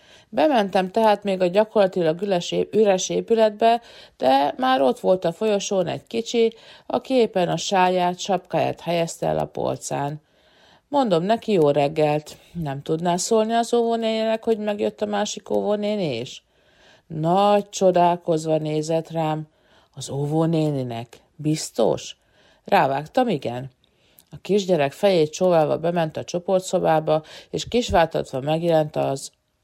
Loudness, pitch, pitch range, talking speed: -22 LUFS, 180 Hz, 155-210 Hz, 120 wpm